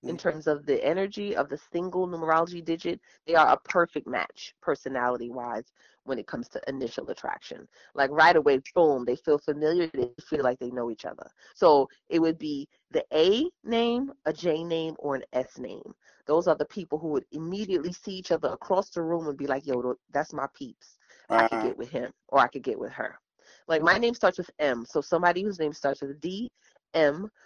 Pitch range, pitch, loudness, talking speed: 140-180 Hz, 160 Hz, -27 LUFS, 210 wpm